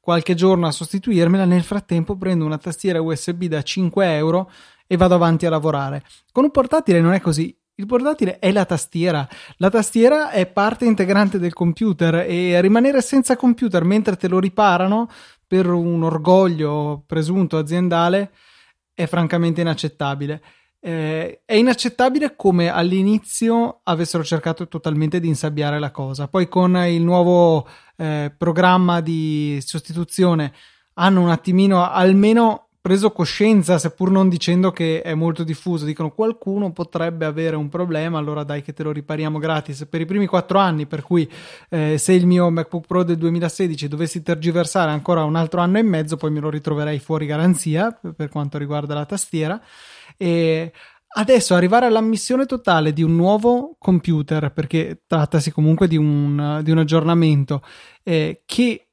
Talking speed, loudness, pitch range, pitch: 155 wpm, -18 LUFS, 160-190 Hz, 175 Hz